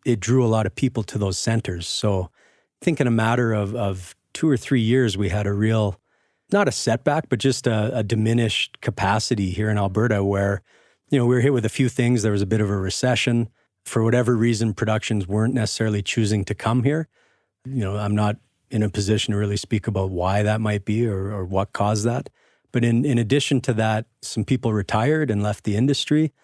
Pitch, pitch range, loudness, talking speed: 110 Hz, 105-125 Hz, -22 LUFS, 220 wpm